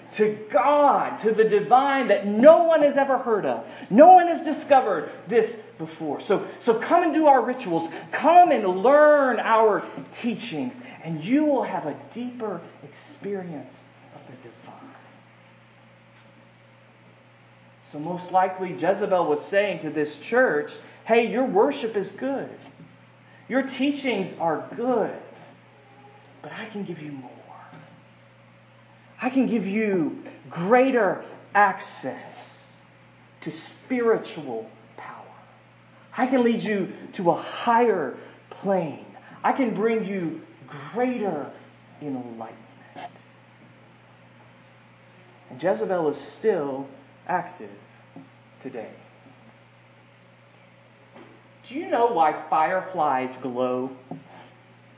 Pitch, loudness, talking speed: 200 Hz, -22 LUFS, 110 wpm